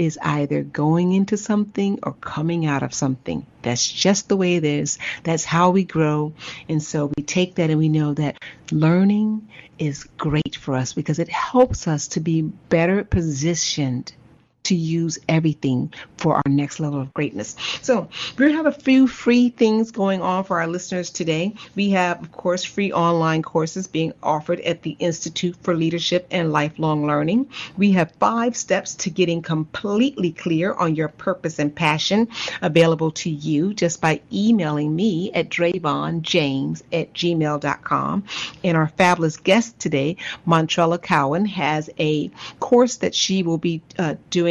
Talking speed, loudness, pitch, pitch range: 165 wpm, -21 LUFS, 170 Hz, 155-190 Hz